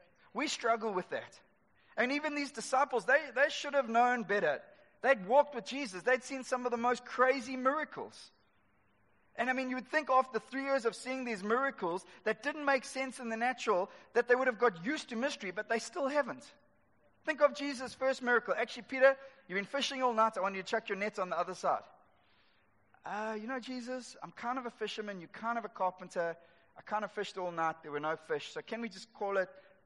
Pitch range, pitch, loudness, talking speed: 200-270 Hz, 240 Hz, -34 LUFS, 220 wpm